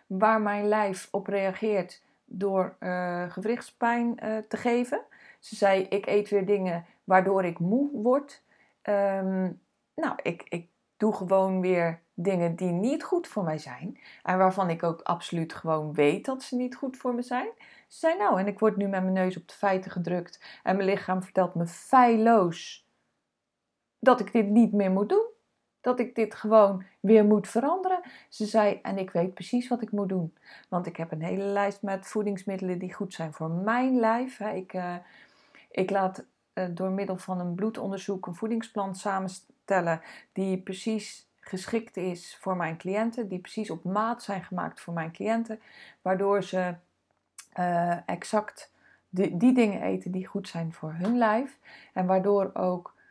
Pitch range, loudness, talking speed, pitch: 185-225 Hz, -28 LUFS, 175 wpm, 195 Hz